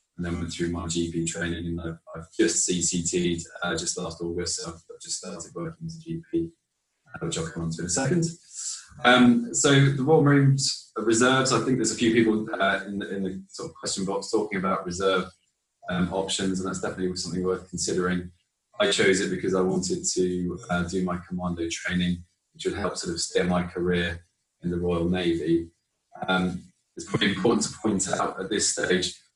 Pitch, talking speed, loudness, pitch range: 90 Hz, 200 wpm, -25 LUFS, 85-115 Hz